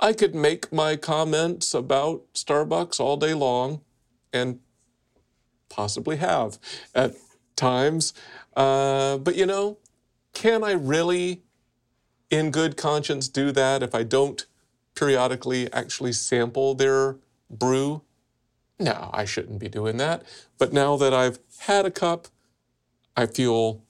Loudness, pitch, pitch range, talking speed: -24 LUFS, 135 Hz, 125-155 Hz, 125 wpm